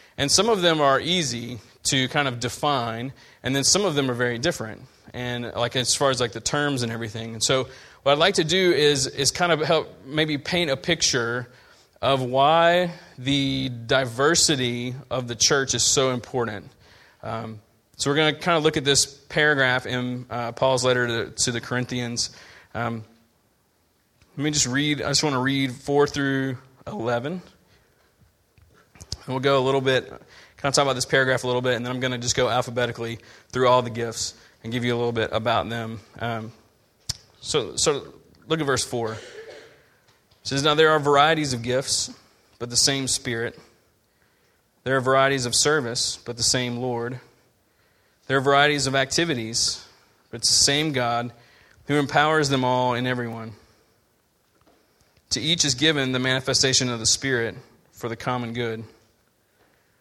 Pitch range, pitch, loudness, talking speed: 120-140 Hz, 130 Hz, -22 LUFS, 175 wpm